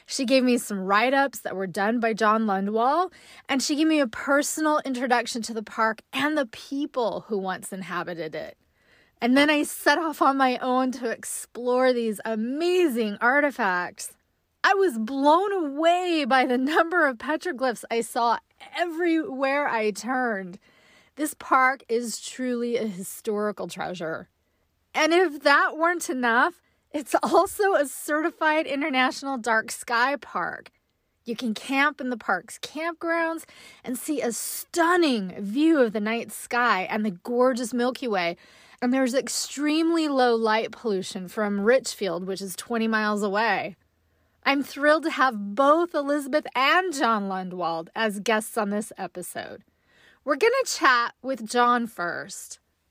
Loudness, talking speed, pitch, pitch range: -24 LUFS, 150 wpm, 250 Hz, 220-300 Hz